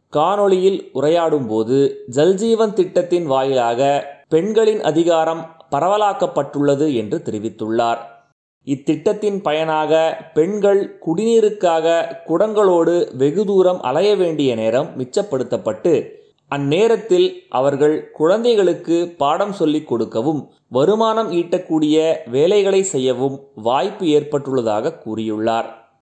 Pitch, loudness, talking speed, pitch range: 160 Hz, -17 LUFS, 80 wpm, 135-195 Hz